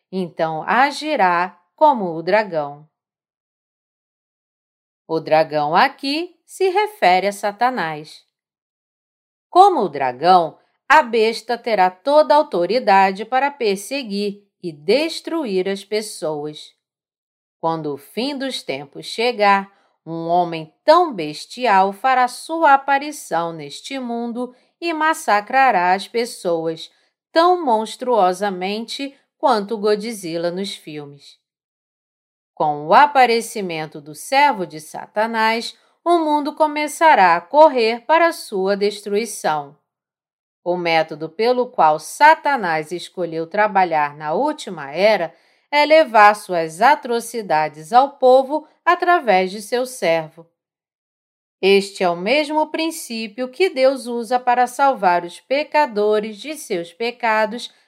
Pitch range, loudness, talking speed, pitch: 175-275 Hz, -18 LUFS, 105 wpm, 215 Hz